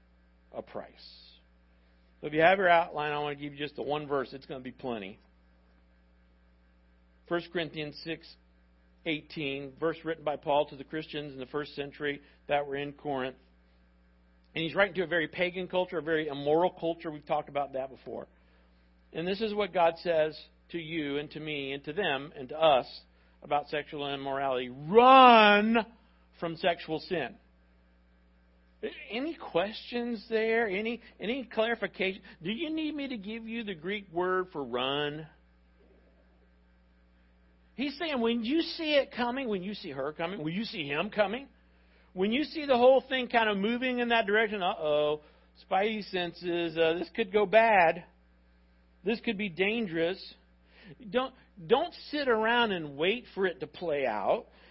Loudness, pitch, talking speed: -29 LUFS, 155 Hz, 165 wpm